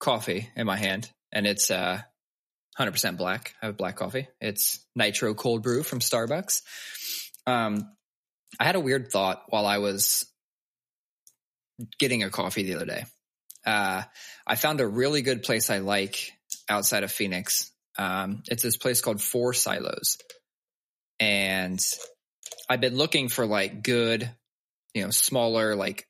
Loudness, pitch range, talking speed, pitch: -26 LUFS, 105-130 Hz, 150 wpm, 120 Hz